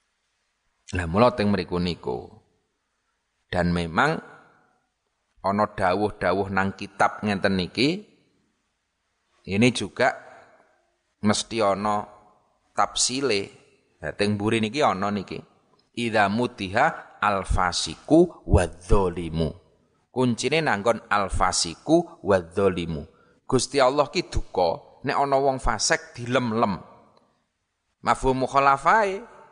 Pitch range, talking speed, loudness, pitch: 95-125 Hz, 90 wpm, -24 LUFS, 105 Hz